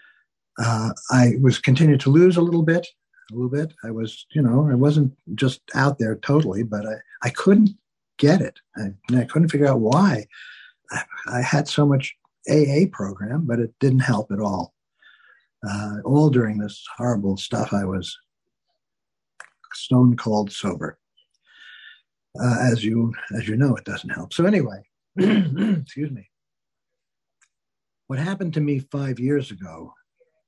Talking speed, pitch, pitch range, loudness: 155 wpm, 130 Hz, 110-150 Hz, -21 LUFS